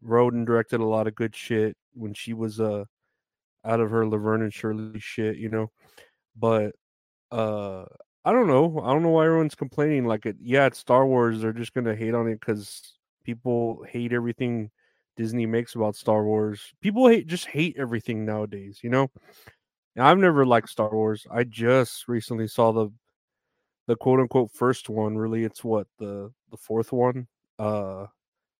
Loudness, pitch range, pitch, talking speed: -24 LUFS, 110-125 Hz, 115 Hz, 175 wpm